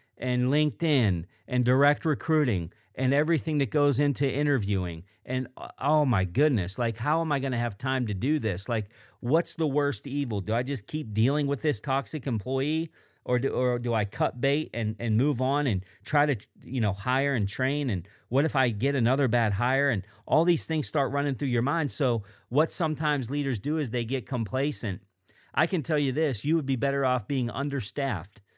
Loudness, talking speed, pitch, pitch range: -27 LUFS, 205 wpm, 135 Hz, 115-145 Hz